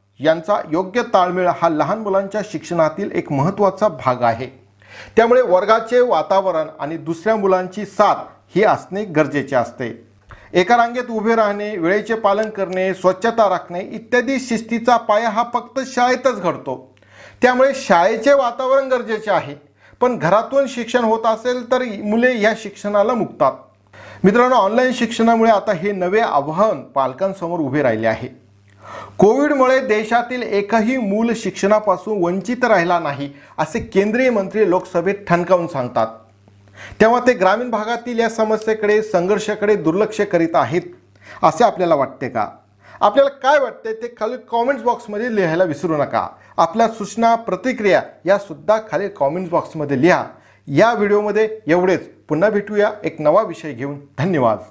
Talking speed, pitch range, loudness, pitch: 135 wpm, 160-230 Hz, -17 LUFS, 205 Hz